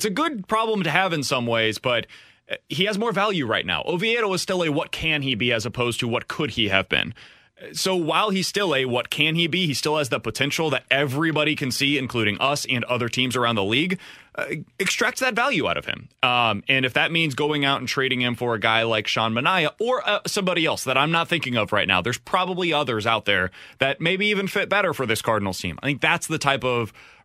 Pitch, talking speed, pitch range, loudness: 145 Hz, 245 wpm, 120-180 Hz, -22 LUFS